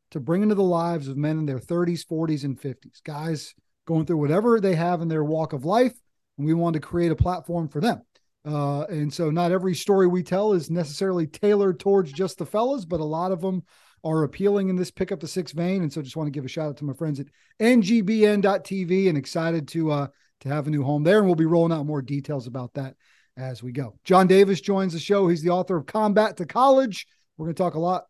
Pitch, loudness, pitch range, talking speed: 170 Hz, -23 LUFS, 150-190 Hz, 245 wpm